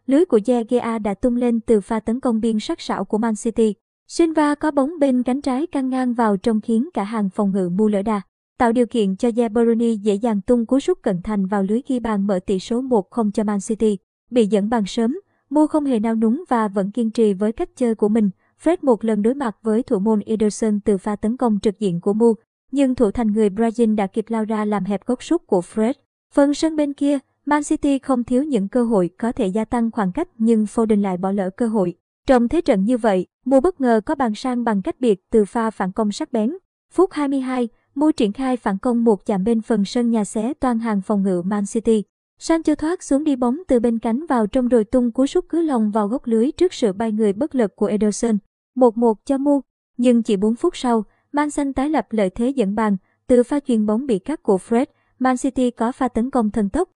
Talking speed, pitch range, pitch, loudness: 245 wpm, 215-260 Hz, 230 Hz, -20 LUFS